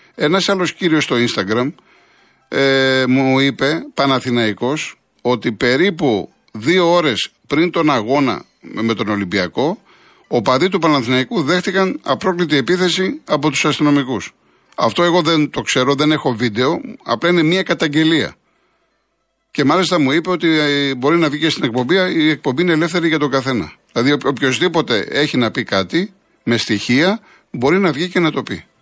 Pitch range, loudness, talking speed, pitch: 130-175 Hz, -16 LUFS, 155 wpm, 150 Hz